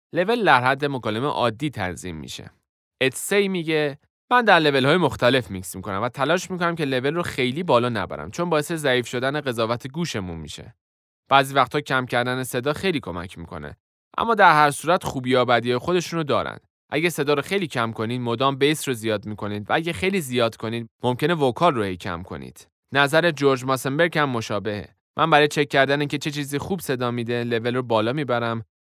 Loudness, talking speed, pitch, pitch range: -22 LUFS, 185 wpm, 130 Hz, 110-150 Hz